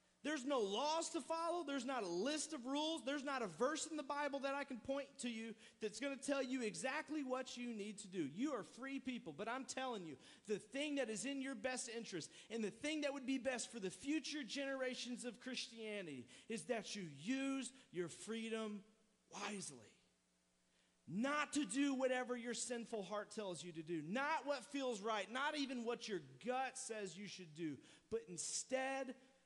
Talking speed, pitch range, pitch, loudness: 200 wpm, 210-275 Hz, 250 Hz, -45 LUFS